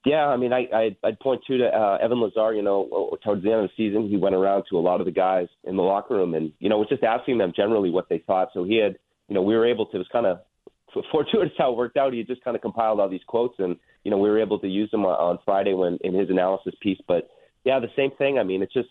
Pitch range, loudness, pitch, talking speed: 95-120 Hz, -23 LUFS, 105 Hz, 300 wpm